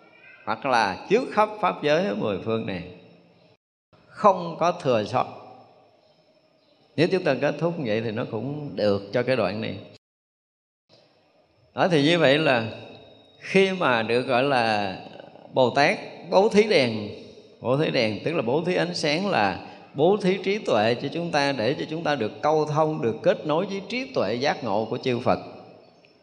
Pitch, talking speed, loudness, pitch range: 145 Hz, 180 wpm, -24 LUFS, 120-170 Hz